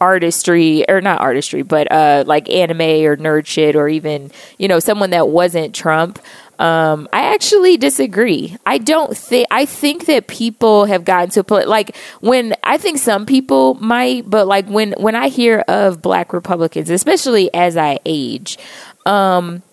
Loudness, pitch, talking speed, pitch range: -13 LUFS, 190 Hz, 170 wpm, 160-230 Hz